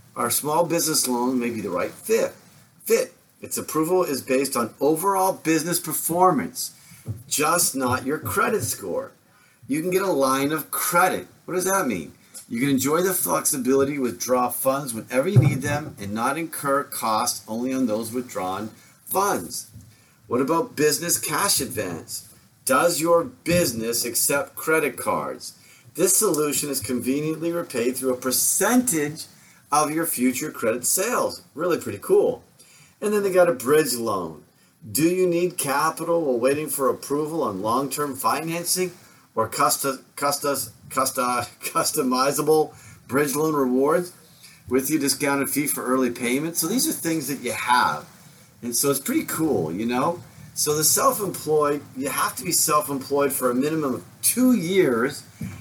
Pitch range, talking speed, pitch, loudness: 130-170 Hz, 155 wpm, 145 Hz, -22 LUFS